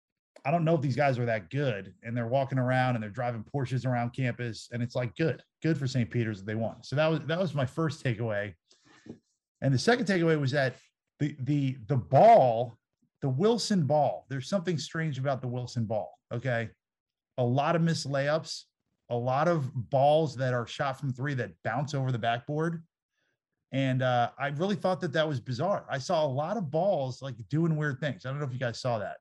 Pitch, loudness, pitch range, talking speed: 135 Hz, -29 LUFS, 120-155 Hz, 215 wpm